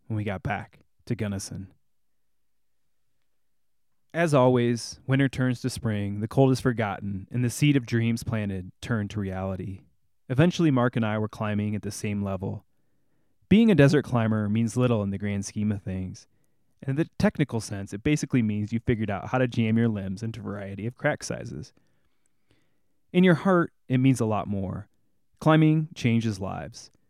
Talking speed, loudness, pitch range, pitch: 175 wpm, -26 LUFS, 100-130 Hz, 115 Hz